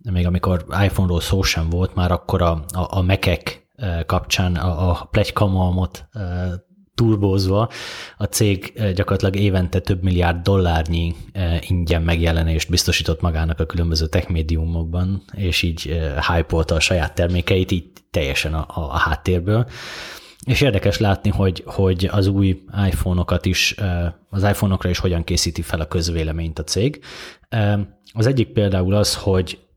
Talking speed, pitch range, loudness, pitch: 140 wpm, 85-100 Hz, -20 LUFS, 90 Hz